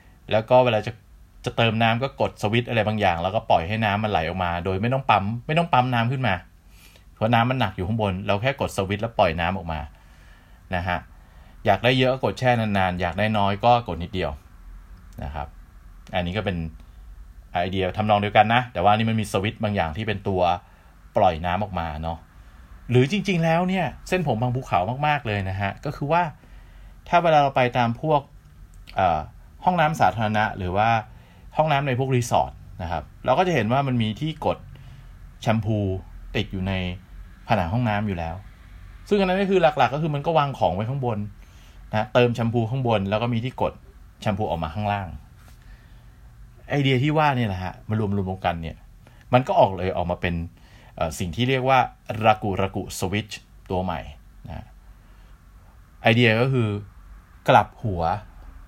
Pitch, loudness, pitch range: 105 Hz, -23 LUFS, 90-120 Hz